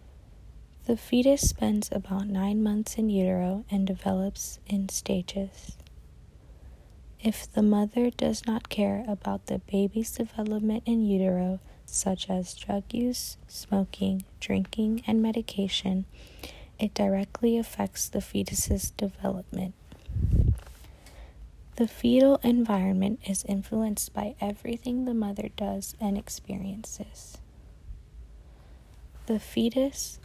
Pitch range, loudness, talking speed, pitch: 185-225 Hz, -28 LUFS, 105 wpm, 200 Hz